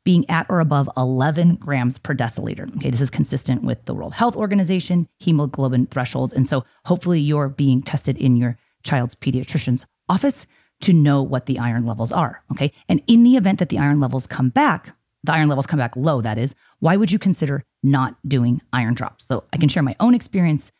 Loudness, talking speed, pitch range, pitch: -20 LUFS, 205 wpm, 130-170 Hz, 140 Hz